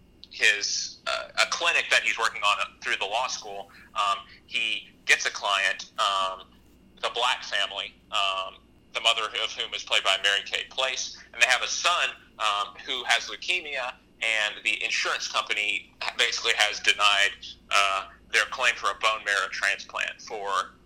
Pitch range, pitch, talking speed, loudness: 95-105 Hz, 100 Hz, 165 wpm, -25 LUFS